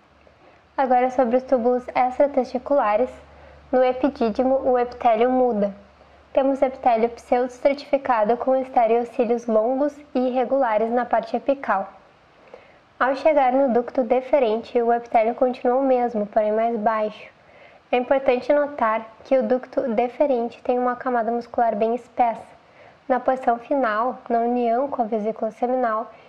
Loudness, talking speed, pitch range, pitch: -21 LUFS, 130 wpm, 235-265 Hz, 250 Hz